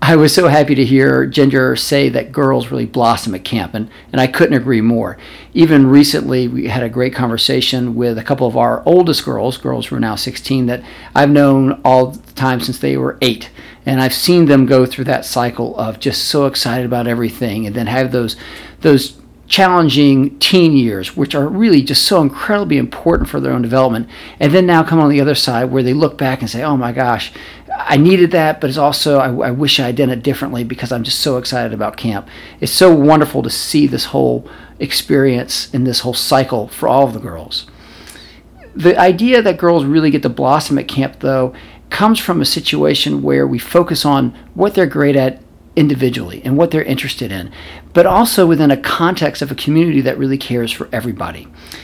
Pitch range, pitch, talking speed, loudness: 120-150 Hz, 135 Hz, 205 wpm, -13 LUFS